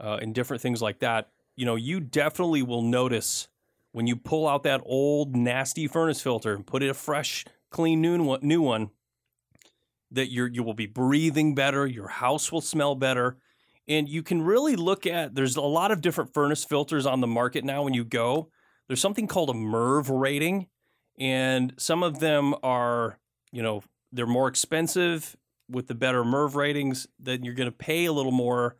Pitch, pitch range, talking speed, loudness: 135 Hz, 125-155 Hz, 190 wpm, -26 LUFS